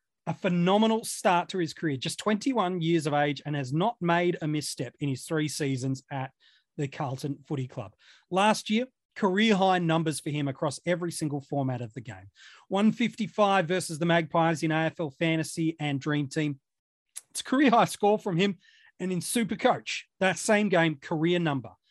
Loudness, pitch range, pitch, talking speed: -28 LUFS, 145-190 Hz, 165 Hz, 180 wpm